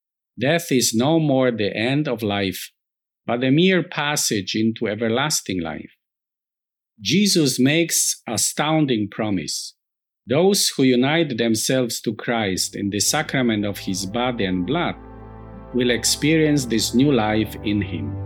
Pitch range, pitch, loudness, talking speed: 105-145 Hz, 120 Hz, -20 LUFS, 130 wpm